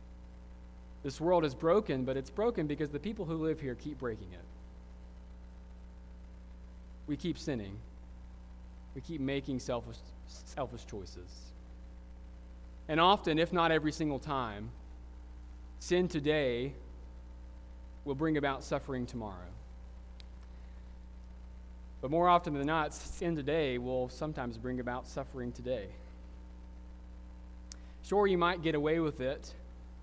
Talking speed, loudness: 120 wpm, -34 LUFS